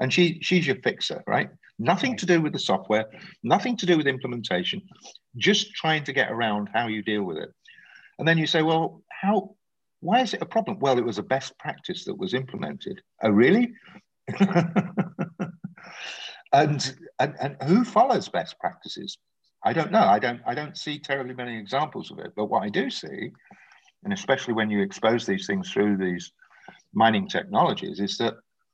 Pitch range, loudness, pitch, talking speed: 125-195 Hz, -25 LUFS, 165 Hz, 180 wpm